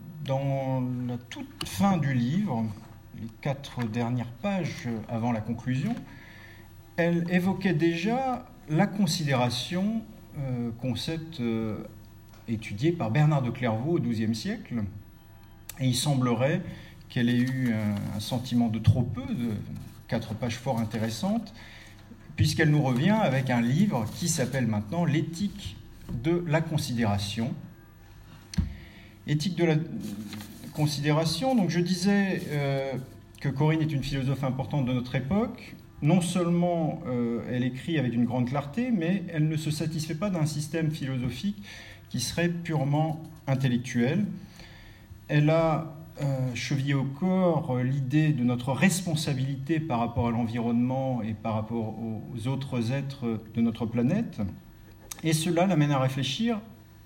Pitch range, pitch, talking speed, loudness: 115-160 Hz, 130 Hz, 130 wpm, -28 LUFS